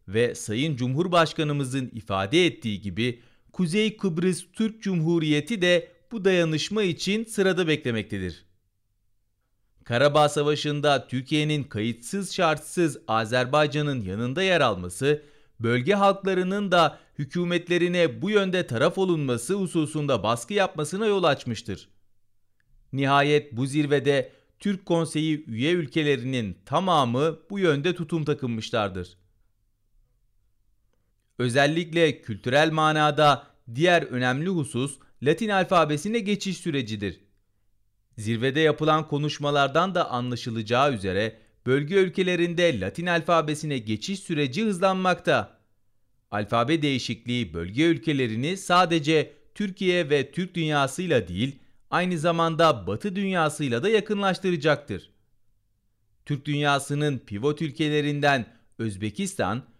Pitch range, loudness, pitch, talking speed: 115-170 Hz, -24 LUFS, 145 Hz, 95 wpm